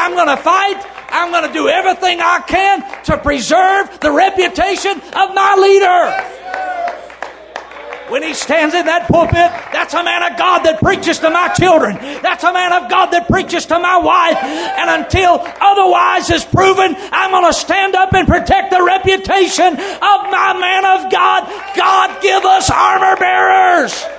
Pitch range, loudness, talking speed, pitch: 345-380 Hz, -12 LUFS, 160 wpm, 365 Hz